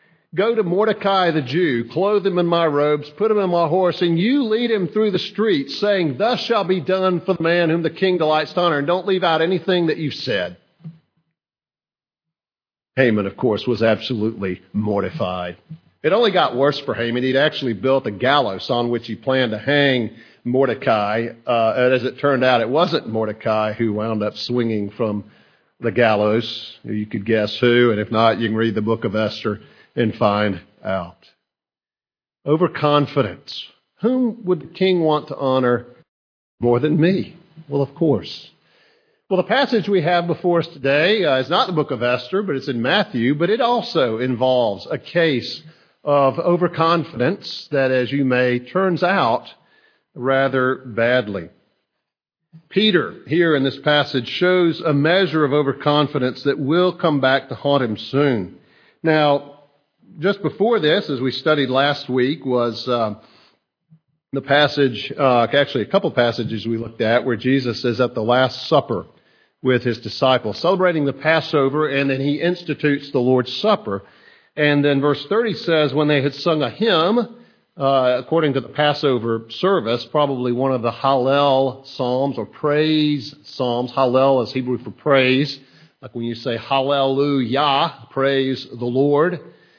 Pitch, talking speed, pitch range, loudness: 140 Hz, 165 wpm, 125-165 Hz, -19 LUFS